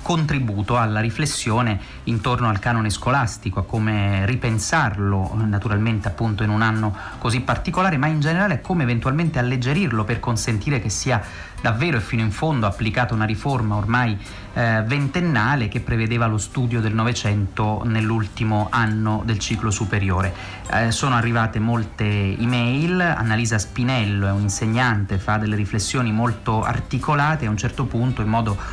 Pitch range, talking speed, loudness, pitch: 105-125 Hz, 150 wpm, -21 LUFS, 115 Hz